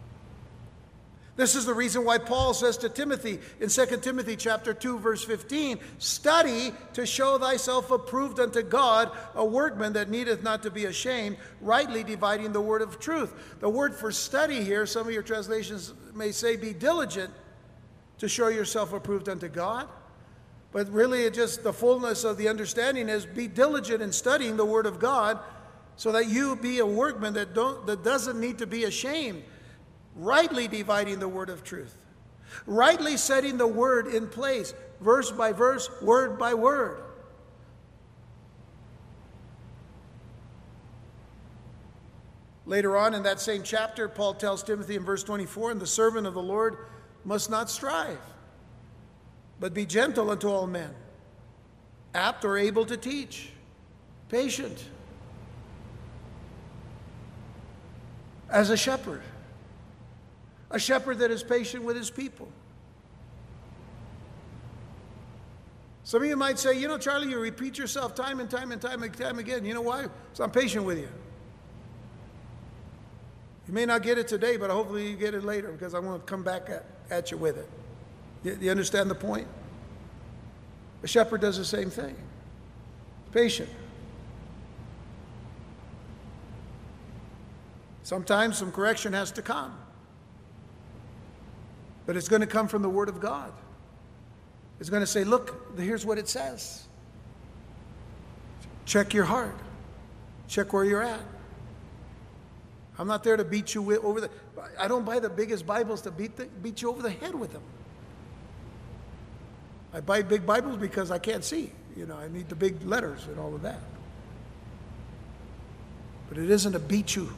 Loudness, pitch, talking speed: -28 LUFS, 210 Hz, 150 wpm